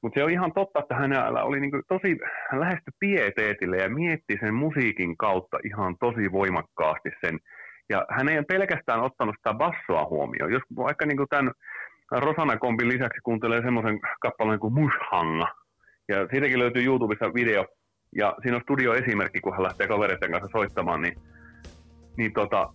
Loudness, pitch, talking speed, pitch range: -26 LUFS, 120 Hz, 160 wpm, 105-140 Hz